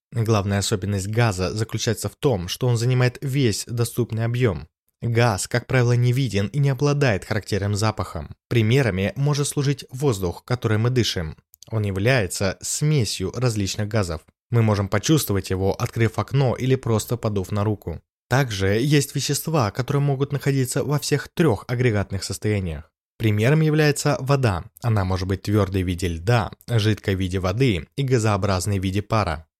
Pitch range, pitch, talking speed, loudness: 100-130 Hz, 110 Hz, 150 wpm, -22 LUFS